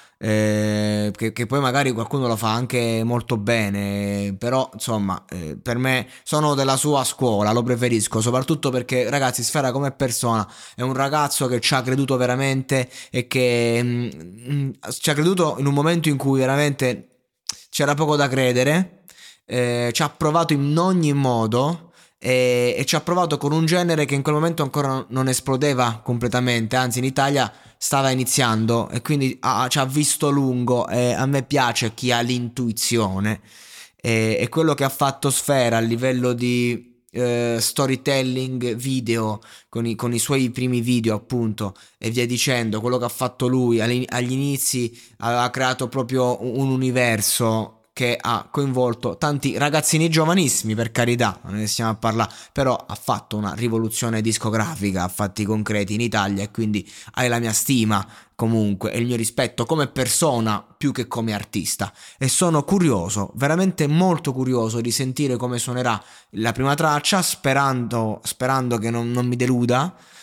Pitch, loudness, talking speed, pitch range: 125 Hz, -21 LUFS, 160 wpm, 115-135 Hz